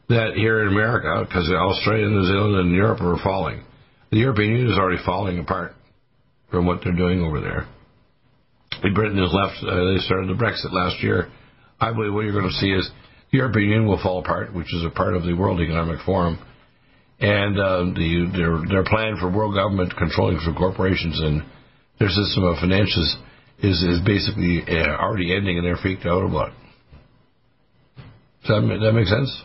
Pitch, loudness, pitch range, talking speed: 95 Hz, -21 LUFS, 90-110 Hz, 190 wpm